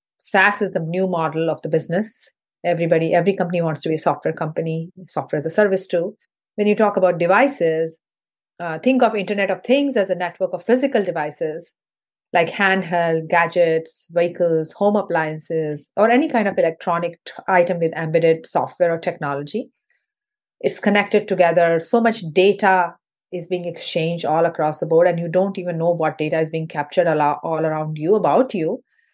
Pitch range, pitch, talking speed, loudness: 165-195 Hz, 175 Hz, 175 wpm, -19 LUFS